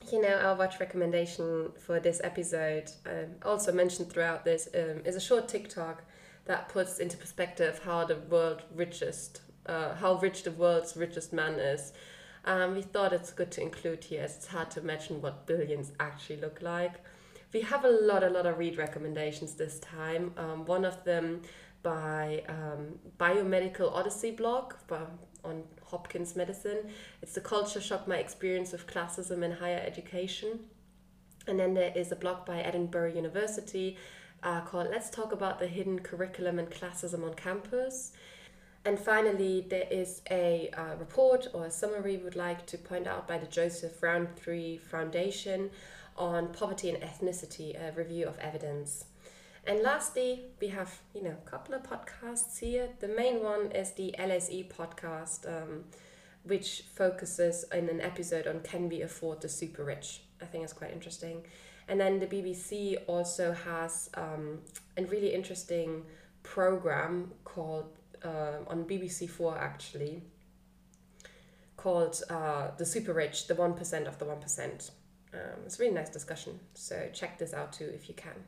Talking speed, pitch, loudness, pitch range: 165 wpm, 175 Hz, -34 LUFS, 165-190 Hz